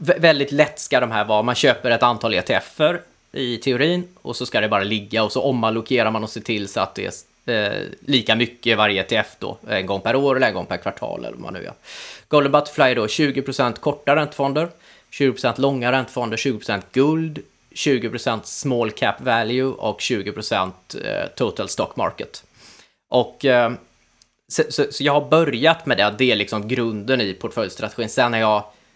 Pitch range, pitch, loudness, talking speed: 110-145 Hz, 125 Hz, -20 LUFS, 190 wpm